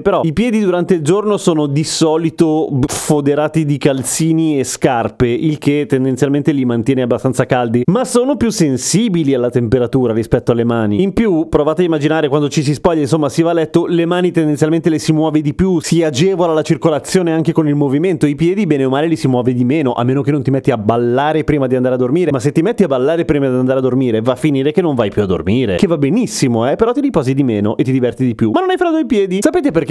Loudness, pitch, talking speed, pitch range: -14 LUFS, 150 Hz, 250 wpm, 130-170 Hz